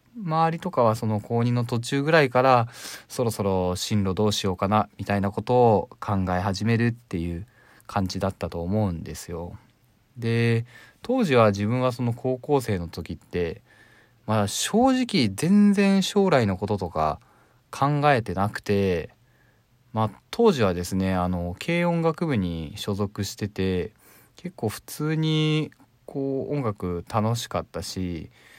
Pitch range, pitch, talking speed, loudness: 100-140 Hz, 115 Hz, 270 characters per minute, -24 LUFS